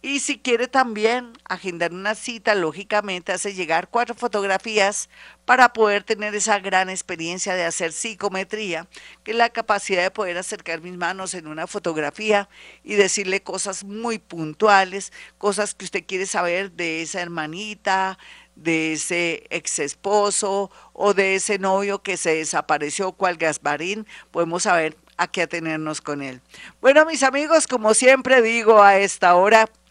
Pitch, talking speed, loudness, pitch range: 195 Hz, 150 wpm, -20 LUFS, 175-215 Hz